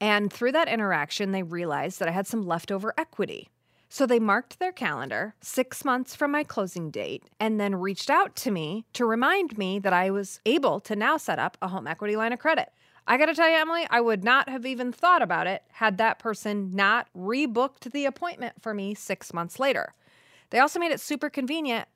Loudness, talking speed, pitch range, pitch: -26 LUFS, 210 wpm, 200-275 Hz, 225 Hz